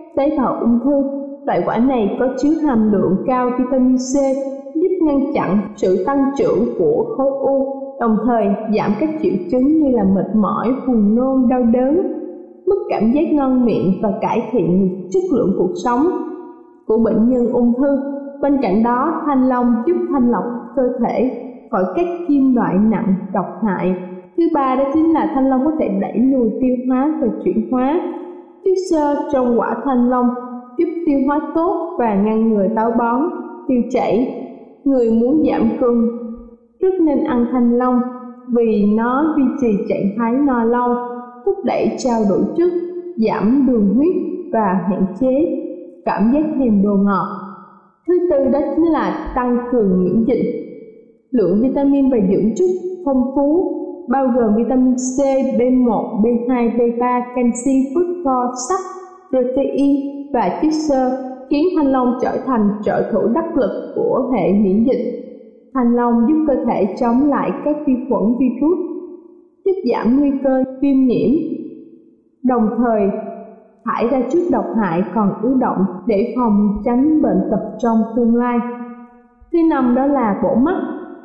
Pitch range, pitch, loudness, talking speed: 235-290 Hz, 255 Hz, -17 LUFS, 165 wpm